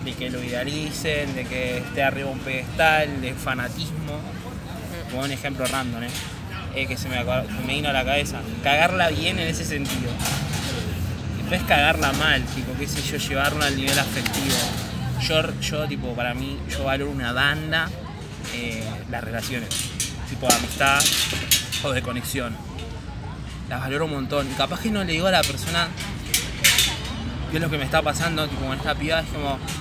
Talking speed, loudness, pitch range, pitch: 175 wpm, -23 LUFS, 115-145 Hz, 130 Hz